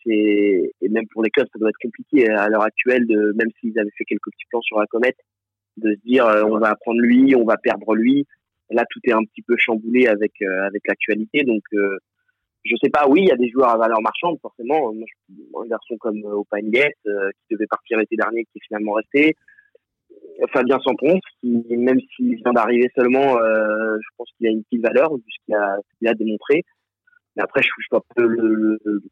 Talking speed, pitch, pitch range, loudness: 230 wpm, 115 Hz, 105-125 Hz, -19 LUFS